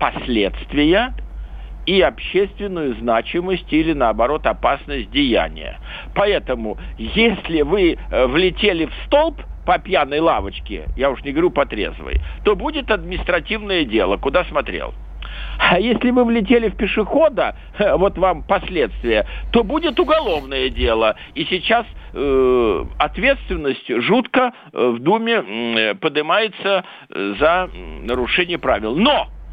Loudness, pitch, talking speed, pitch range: -18 LUFS, 195 Hz, 110 wpm, 150-240 Hz